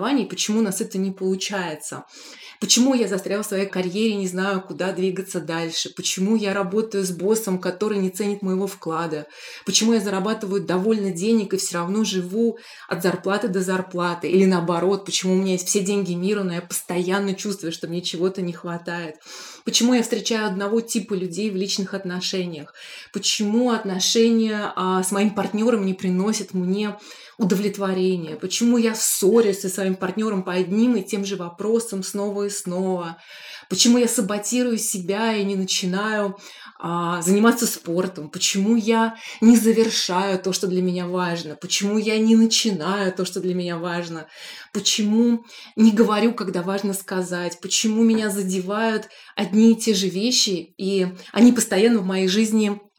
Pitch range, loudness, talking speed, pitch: 185-220 Hz, -21 LUFS, 160 wpm, 195 Hz